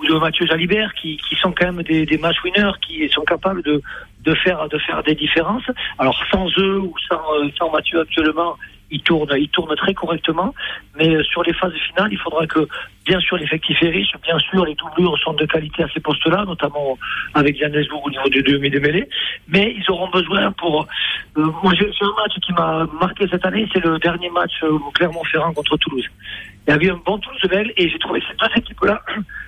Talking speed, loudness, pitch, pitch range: 210 wpm, -18 LUFS, 170 Hz, 155-185 Hz